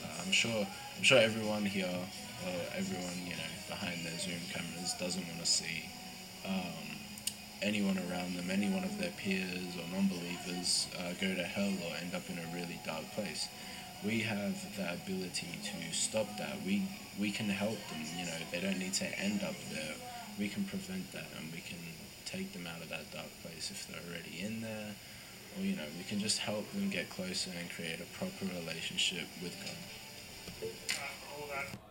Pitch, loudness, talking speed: 105 Hz, -37 LUFS, 185 wpm